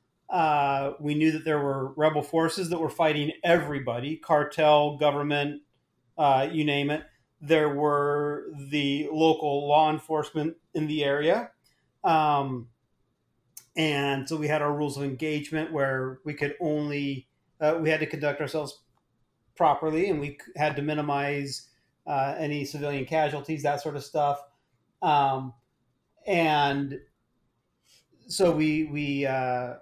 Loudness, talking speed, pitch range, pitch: -27 LUFS, 135 wpm, 140-155 Hz, 145 Hz